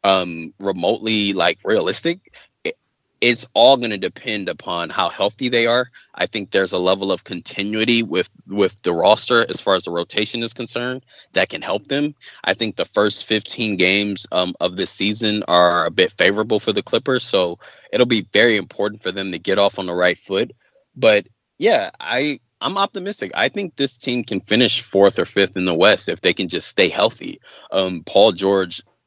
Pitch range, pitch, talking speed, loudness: 95-120 Hz, 105 Hz, 195 wpm, -18 LUFS